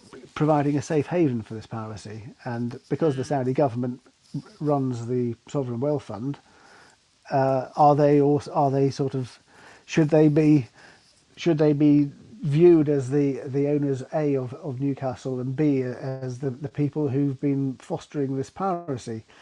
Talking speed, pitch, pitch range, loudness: 160 wpm, 140 Hz, 130-145 Hz, -24 LUFS